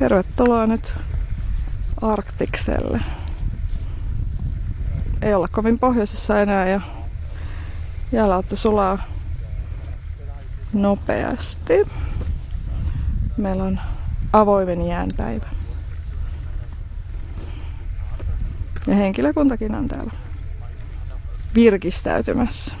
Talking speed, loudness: 55 wpm, -22 LUFS